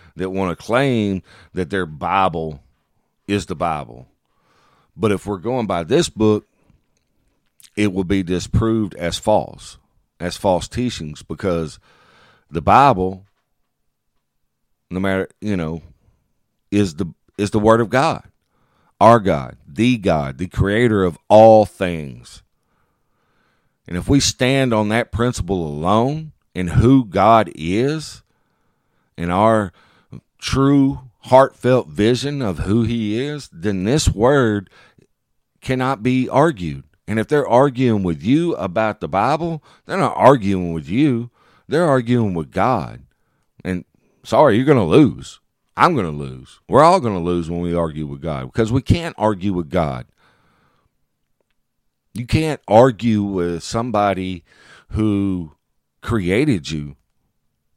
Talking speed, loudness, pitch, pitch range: 130 wpm, -18 LUFS, 100 Hz, 85-120 Hz